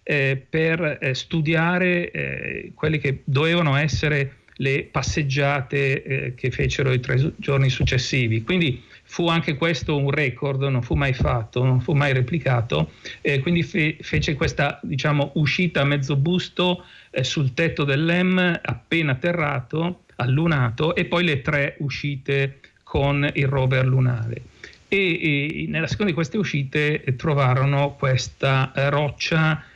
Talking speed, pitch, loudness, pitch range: 125 wpm, 145 Hz, -22 LUFS, 135-165 Hz